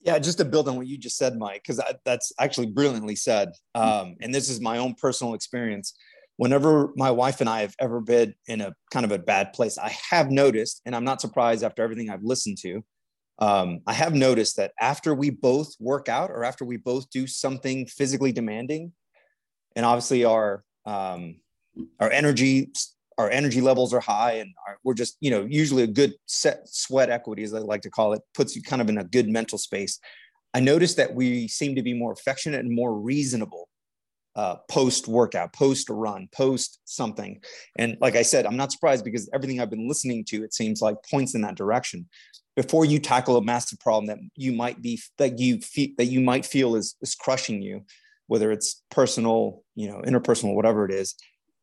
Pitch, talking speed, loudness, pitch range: 125 Hz, 205 wpm, -24 LUFS, 110-135 Hz